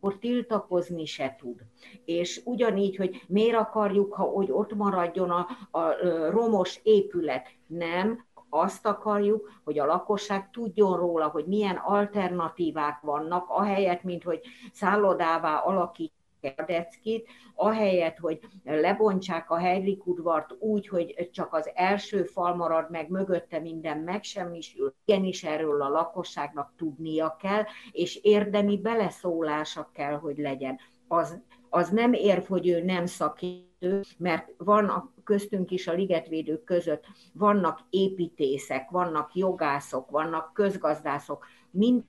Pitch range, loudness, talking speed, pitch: 160-205 Hz, -28 LUFS, 125 wpm, 180 Hz